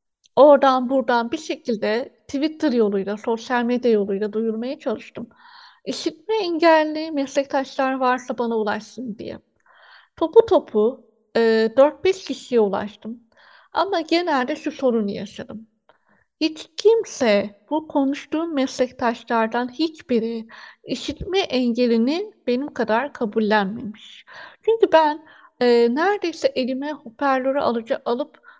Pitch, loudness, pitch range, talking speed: 265 Hz, -21 LUFS, 230-315 Hz, 100 wpm